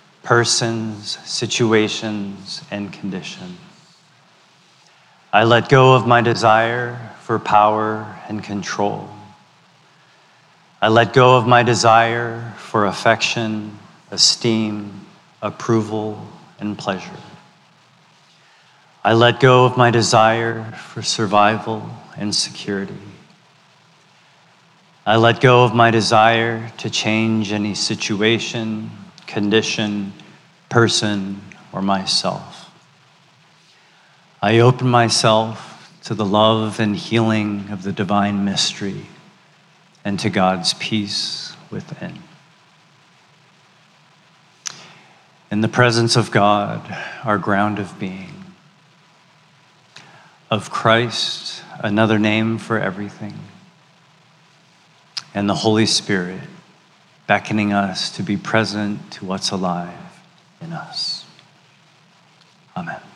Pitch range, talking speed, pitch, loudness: 105-145 Hz, 90 wpm, 115 Hz, -17 LUFS